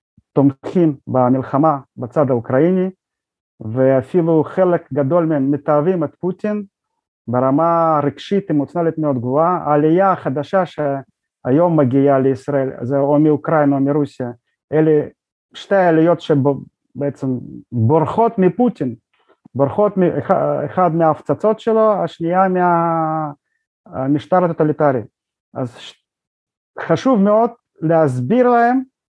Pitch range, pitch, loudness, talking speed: 140-180 Hz, 155 Hz, -16 LUFS, 95 wpm